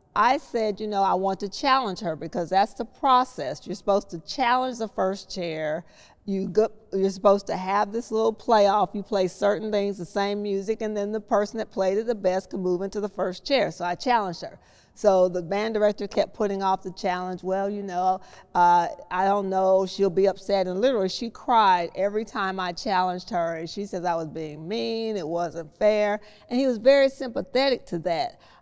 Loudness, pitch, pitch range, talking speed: -25 LUFS, 200 Hz, 185-220 Hz, 210 wpm